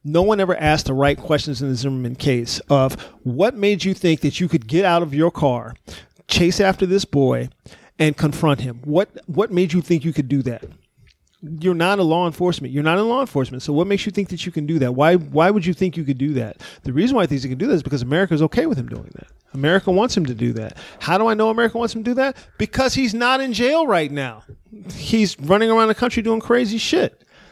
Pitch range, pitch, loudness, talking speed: 140-205 Hz, 170 Hz, -19 LUFS, 255 wpm